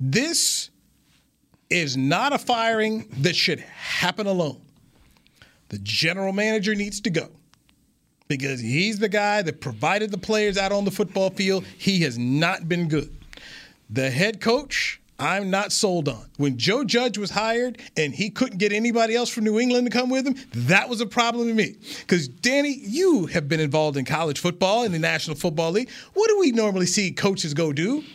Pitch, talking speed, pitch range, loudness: 195 Hz, 185 wpm, 155-225 Hz, -23 LUFS